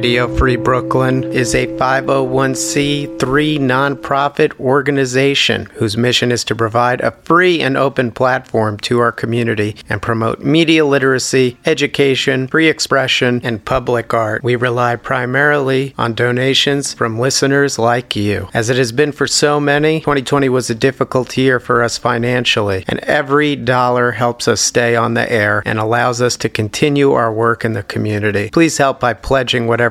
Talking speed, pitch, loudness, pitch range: 160 wpm, 125 Hz, -14 LUFS, 115-140 Hz